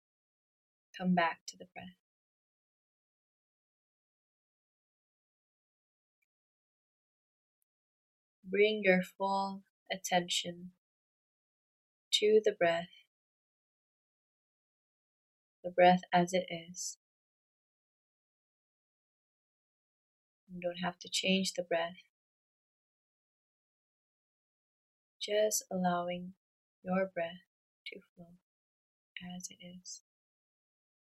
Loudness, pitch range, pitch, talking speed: -33 LUFS, 175-190 Hz, 180 Hz, 65 wpm